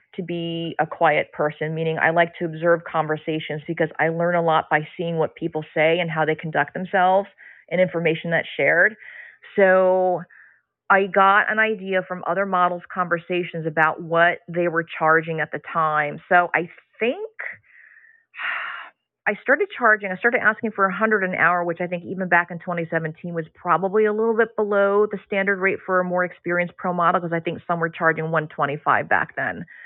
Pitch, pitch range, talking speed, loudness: 175 Hz, 160-195 Hz, 185 wpm, -21 LUFS